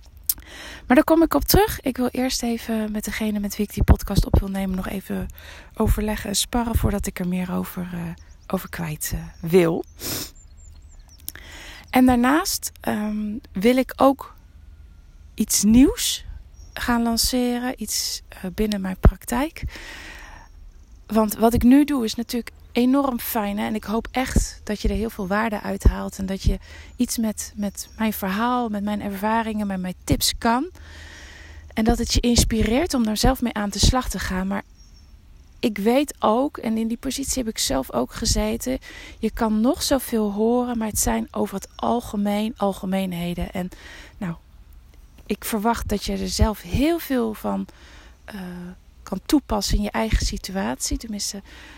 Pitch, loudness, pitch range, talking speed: 210 Hz, -23 LUFS, 175-235 Hz, 170 wpm